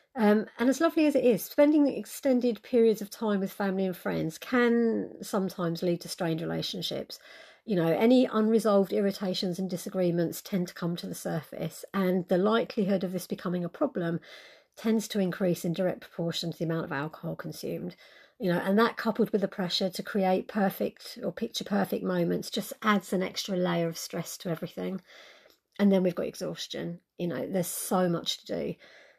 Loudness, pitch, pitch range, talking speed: -29 LUFS, 195 Hz, 175-220 Hz, 190 wpm